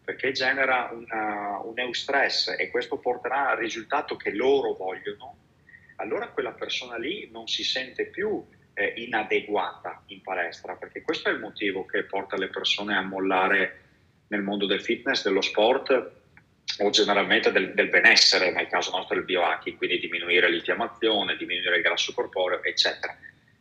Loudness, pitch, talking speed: -25 LUFS, 370 Hz, 155 wpm